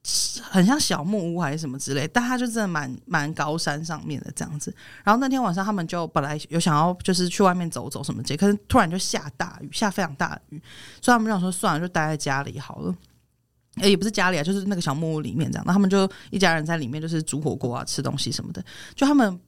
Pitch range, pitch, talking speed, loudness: 150-200 Hz, 175 Hz, 375 characters per minute, -24 LUFS